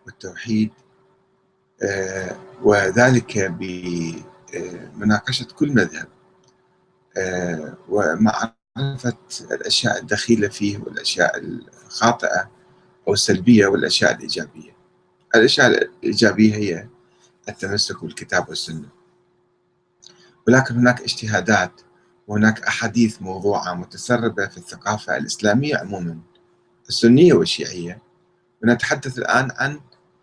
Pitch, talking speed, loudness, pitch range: 110 Hz, 75 wpm, -19 LUFS, 95-125 Hz